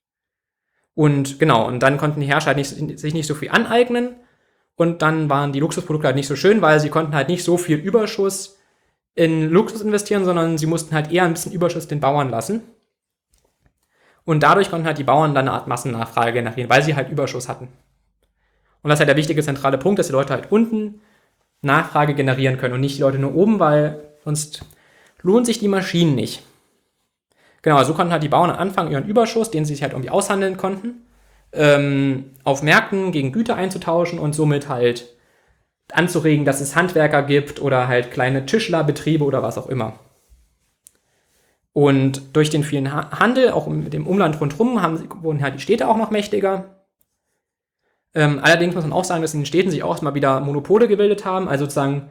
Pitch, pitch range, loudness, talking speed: 155 Hz, 140-185 Hz, -18 LUFS, 185 wpm